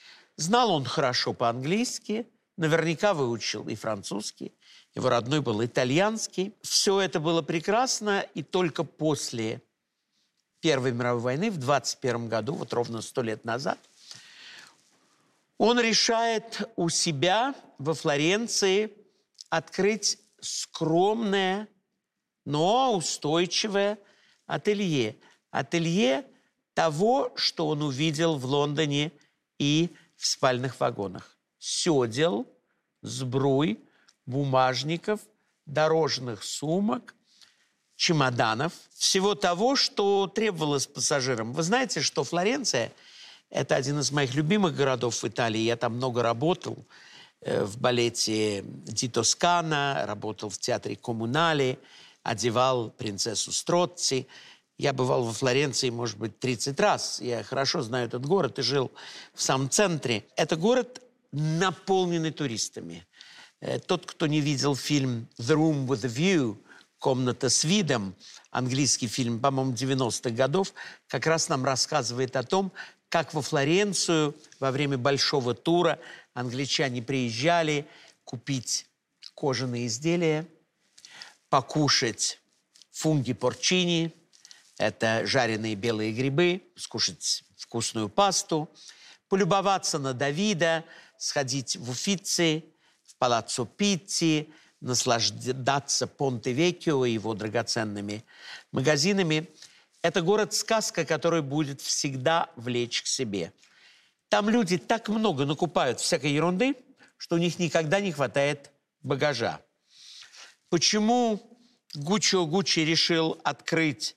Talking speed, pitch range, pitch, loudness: 105 wpm, 130-185 Hz, 155 Hz, -27 LUFS